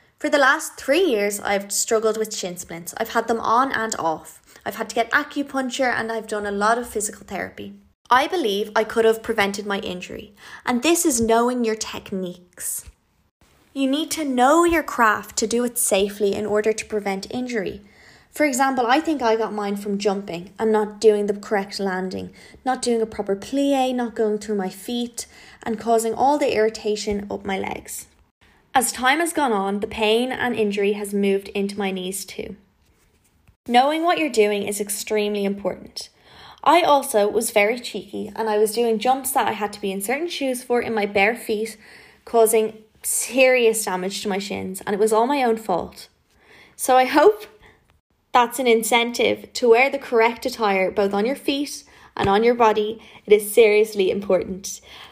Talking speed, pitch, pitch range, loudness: 185 wpm, 220 Hz, 205-245 Hz, -21 LUFS